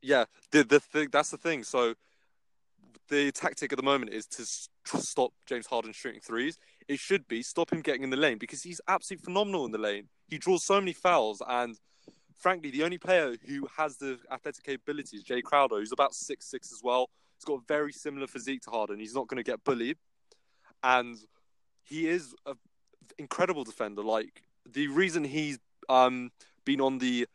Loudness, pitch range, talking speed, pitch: -30 LUFS, 125-165 Hz, 195 wpm, 140 Hz